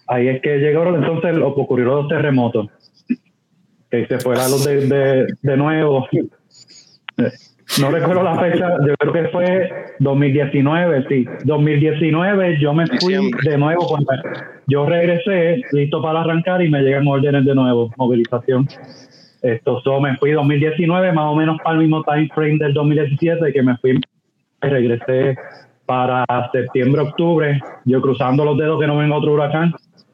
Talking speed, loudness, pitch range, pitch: 150 wpm, -17 LUFS, 135-165 Hz, 145 Hz